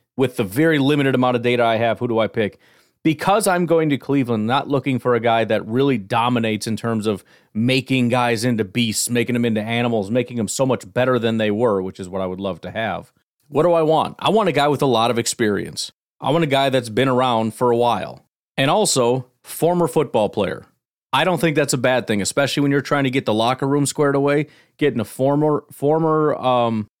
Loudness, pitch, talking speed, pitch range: -19 LUFS, 125 Hz, 230 wpm, 115-145 Hz